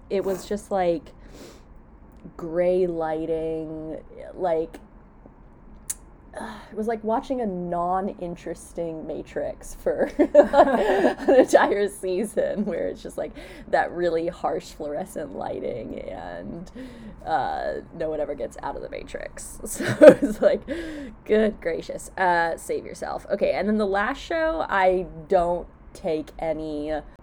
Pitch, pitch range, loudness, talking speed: 185 Hz, 165-235 Hz, -24 LUFS, 125 wpm